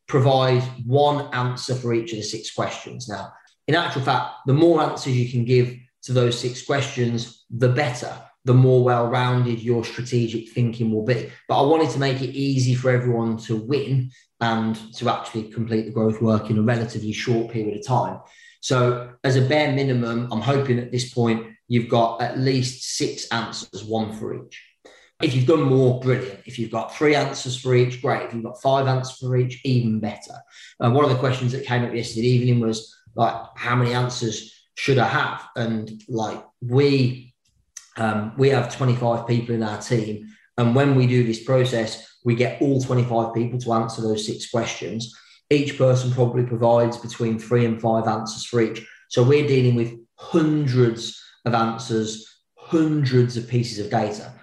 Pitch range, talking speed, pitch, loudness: 115-130 Hz, 185 wpm, 120 Hz, -22 LUFS